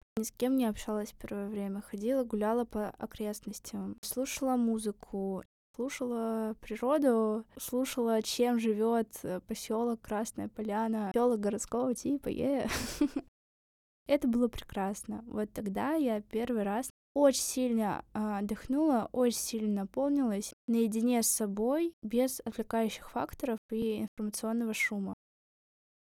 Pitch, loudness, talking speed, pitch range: 225 Hz, -33 LUFS, 115 wpm, 215-250 Hz